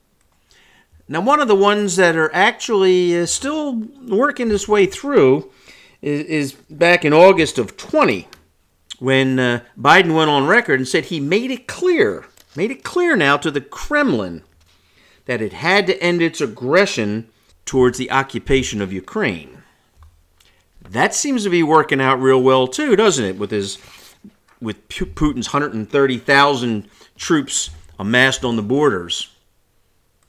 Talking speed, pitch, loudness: 145 wpm, 140 Hz, -16 LUFS